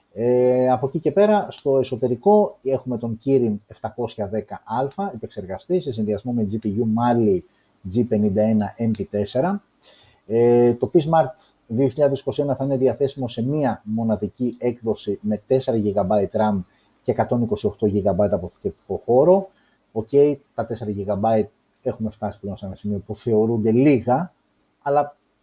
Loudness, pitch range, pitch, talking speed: -21 LUFS, 105-135 Hz, 120 Hz, 125 wpm